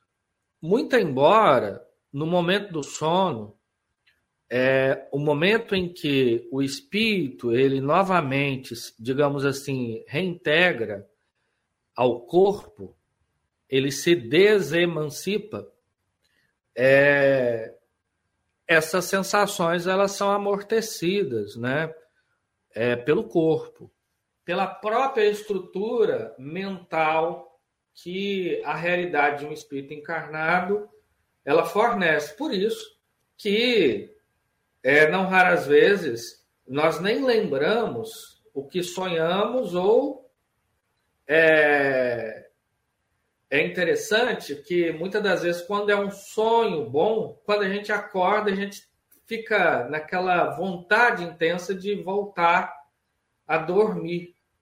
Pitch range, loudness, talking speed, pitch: 140-200 Hz, -23 LUFS, 95 wpm, 170 Hz